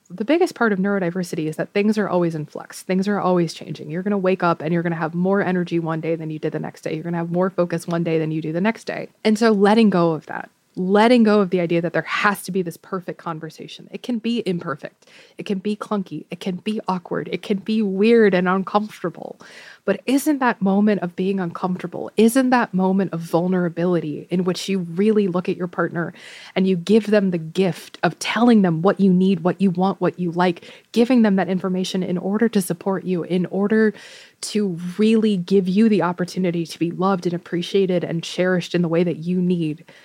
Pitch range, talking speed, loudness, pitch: 170-205 Hz, 230 wpm, -20 LUFS, 185 Hz